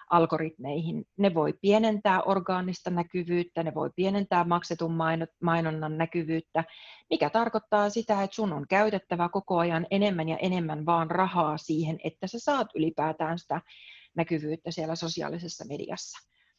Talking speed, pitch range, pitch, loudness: 130 wpm, 160-190 Hz, 170 Hz, -29 LUFS